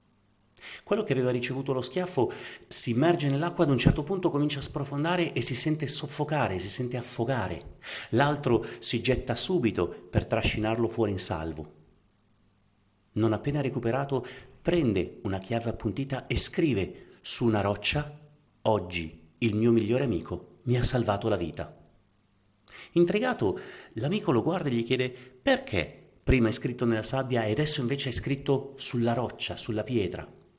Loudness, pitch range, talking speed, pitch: -28 LUFS, 105-140 Hz, 150 wpm, 120 Hz